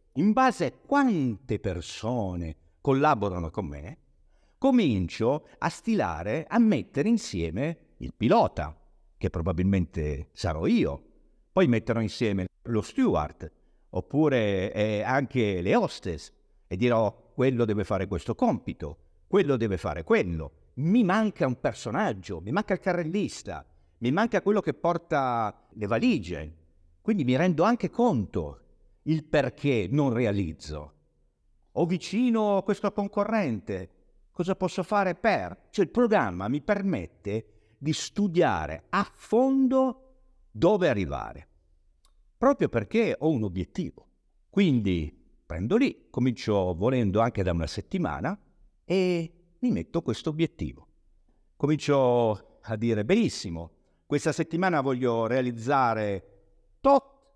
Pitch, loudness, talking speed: 125 Hz, -27 LUFS, 120 wpm